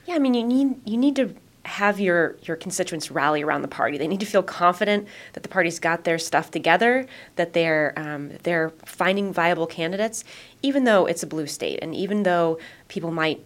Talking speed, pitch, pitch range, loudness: 205 wpm, 175 Hz, 165-210 Hz, -23 LUFS